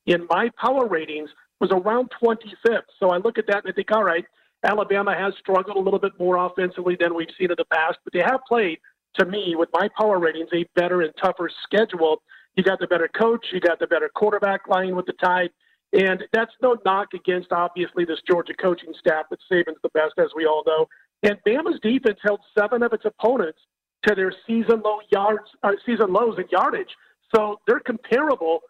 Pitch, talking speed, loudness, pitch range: 195 Hz, 205 wpm, -22 LUFS, 175-220 Hz